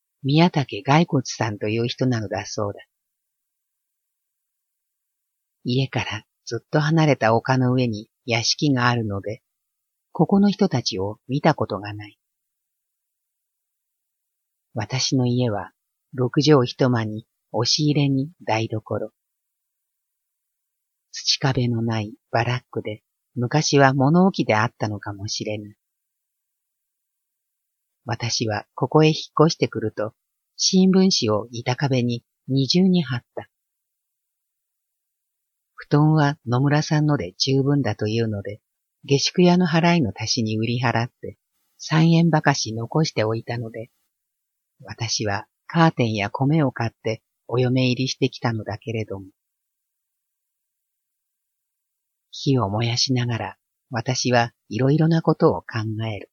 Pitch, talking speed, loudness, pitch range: 125 Hz, 220 characters per minute, -21 LUFS, 110-145 Hz